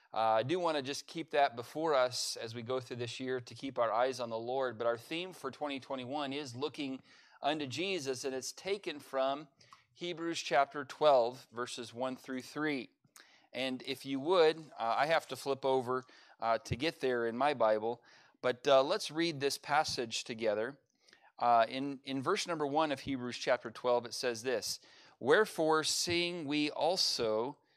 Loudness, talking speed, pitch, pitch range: -34 LUFS, 180 wpm, 135 Hz, 125-150 Hz